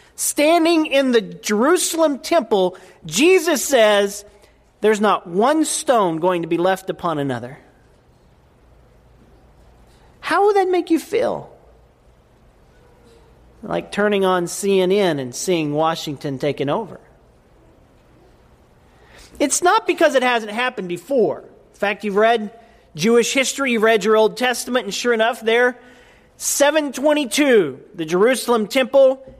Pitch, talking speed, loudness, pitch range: 225 Hz, 120 wpm, -18 LUFS, 185-280 Hz